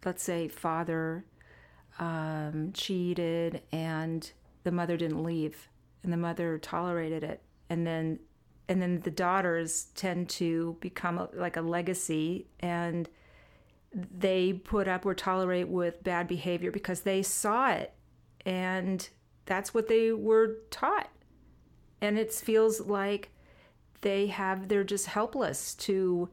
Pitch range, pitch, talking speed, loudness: 165-190 Hz, 175 Hz, 130 wpm, -31 LUFS